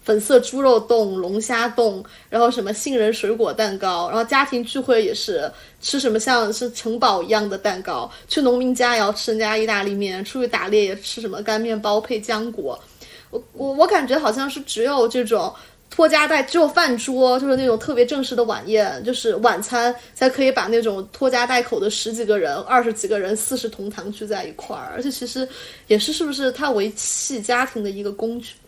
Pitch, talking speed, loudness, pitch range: 235 Hz, 310 characters per minute, -20 LUFS, 215-260 Hz